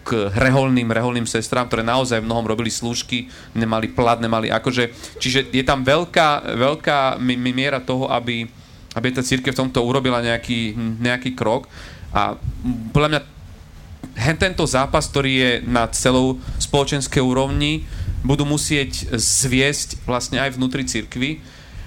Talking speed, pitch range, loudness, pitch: 135 wpm, 115-135 Hz, -19 LUFS, 125 Hz